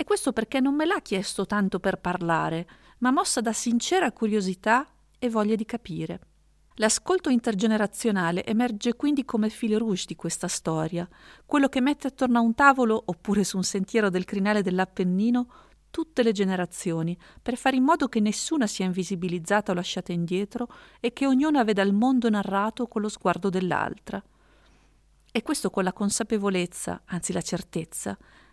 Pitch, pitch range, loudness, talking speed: 215 Hz, 185-245 Hz, -26 LUFS, 160 wpm